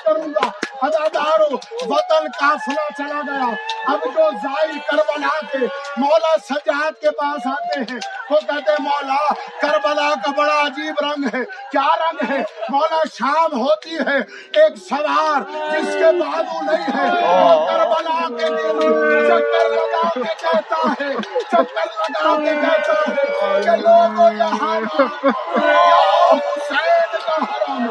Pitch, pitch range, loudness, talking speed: 300 Hz, 280-315 Hz, -17 LUFS, 135 wpm